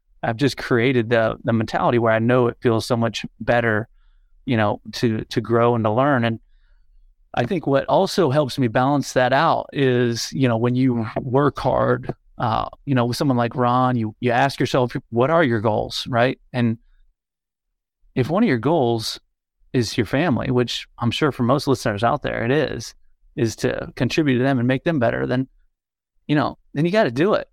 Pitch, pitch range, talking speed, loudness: 120 Hz, 115-135 Hz, 200 wpm, -20 LUFS